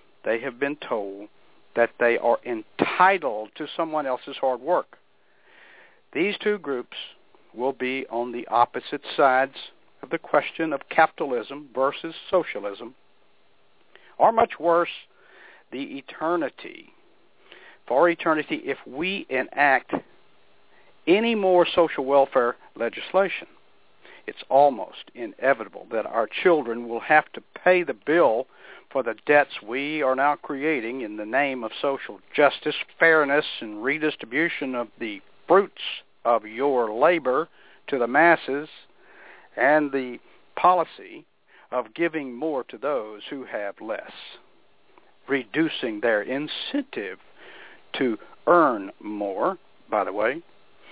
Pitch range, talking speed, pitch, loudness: 130-180 Hz, 120 wpm, 150 Hz, -24 LUFS